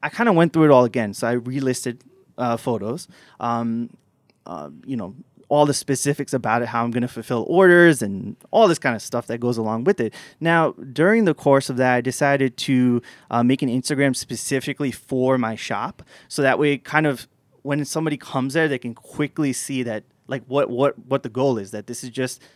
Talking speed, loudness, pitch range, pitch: 215 wpm, -21 LUFS, 120-145 Hz, 130 Hz